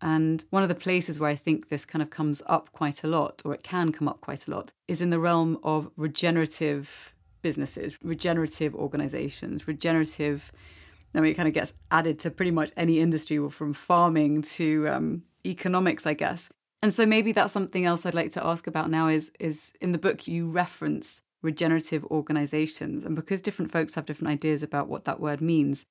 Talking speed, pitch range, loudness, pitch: 200 wpm, 150-170 Hz, -27 LUFS, 160 Hz